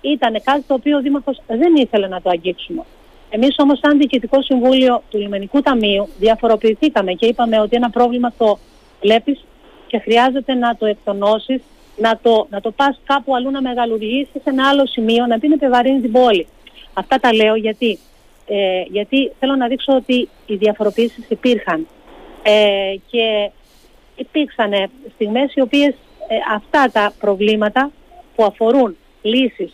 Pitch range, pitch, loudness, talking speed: 215-275 Hz, 240 Hz, -16 LUFS, 155 wpm